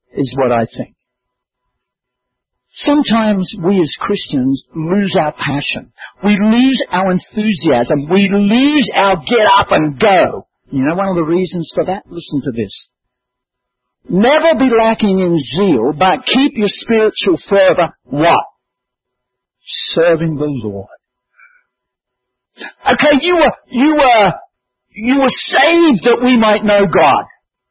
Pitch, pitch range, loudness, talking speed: 195 Hz, 145-235 Hz, -12 LUFS, 130 wpm